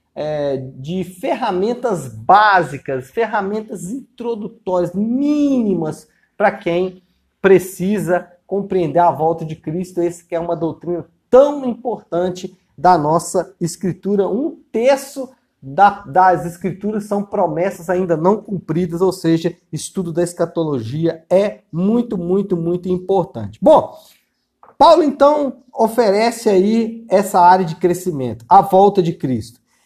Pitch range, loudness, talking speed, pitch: 170-210 Hz, -17 LUFS, 115 wpm, 185 Hz